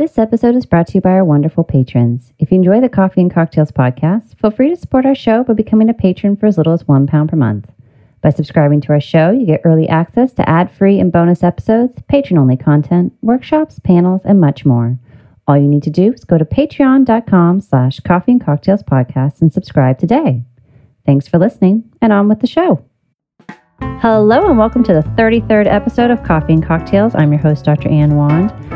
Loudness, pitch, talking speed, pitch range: -12 LUFS, 175 Hz, 205 wpm, 145-215 Hz